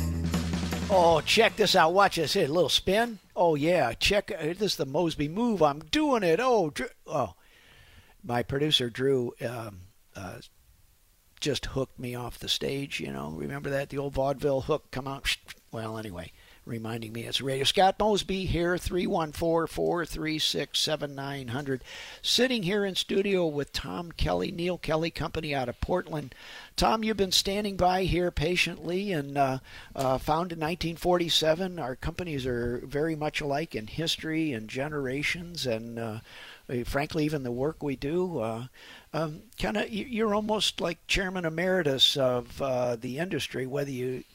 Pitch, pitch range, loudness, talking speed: 150 Hz, 130-175 Hz, -28 LUFS, 155 wpm